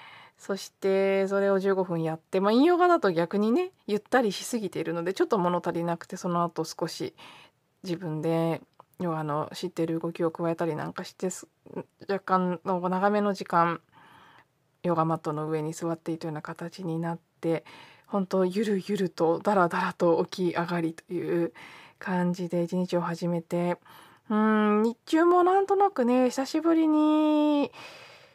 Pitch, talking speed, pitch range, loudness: 180 Hz, 295 characters per minute, 170-205 Hz, -27 LUFS